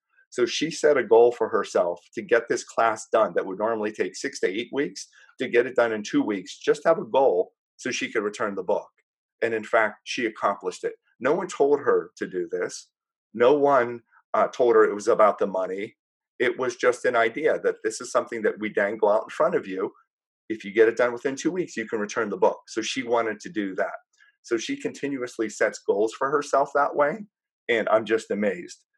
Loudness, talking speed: -24 LUFS, 225 wpm